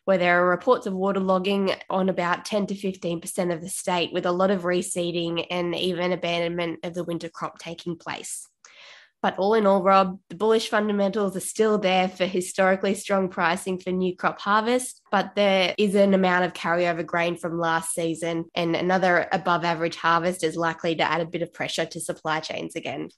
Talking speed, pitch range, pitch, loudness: 195 wpm, 170-195 Hz, 180 Hz, -24 LUFS